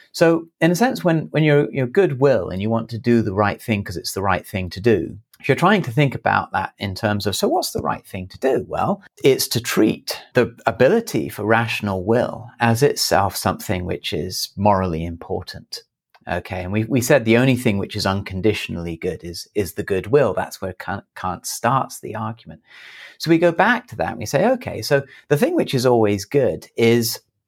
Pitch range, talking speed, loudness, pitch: 100-140 Hz, 215 wpm, -20 LUFS, 115 Hz